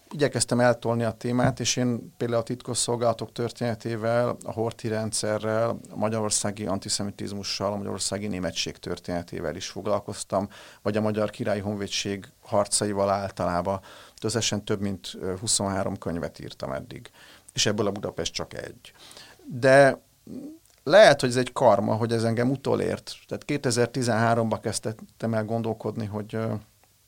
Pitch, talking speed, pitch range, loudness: 110 Hz, 130 wpm, 100-120 Hz, -26 LUFS